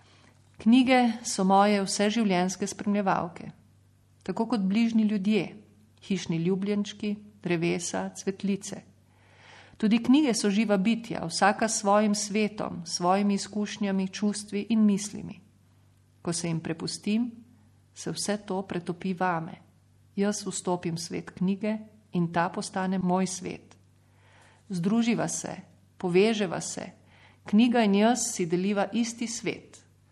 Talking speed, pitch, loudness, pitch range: 115 wpm, 195 Hz, -27 LUFS, 175-210 Hz